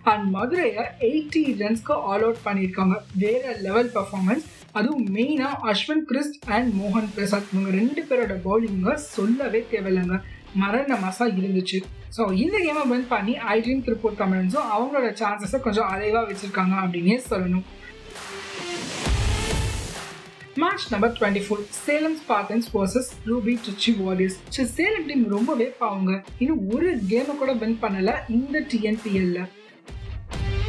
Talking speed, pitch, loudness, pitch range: 125 wpm, 220 Hz, -24 LUFS, 195-255 Hz